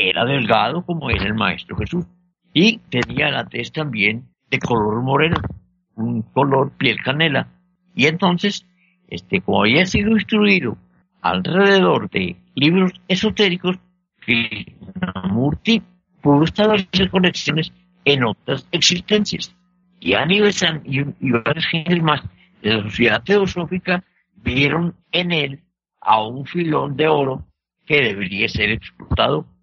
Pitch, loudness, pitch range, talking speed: 165 Hz, -18 LUFS, 125-180 Hz, 125 wpm